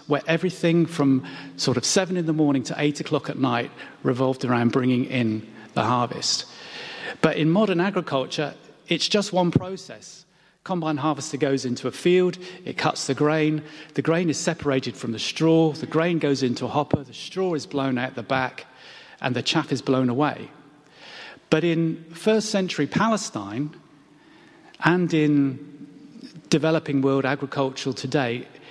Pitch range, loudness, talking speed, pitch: 135-165 Hz, -23 LUFS, 155 wpm, 150 Hz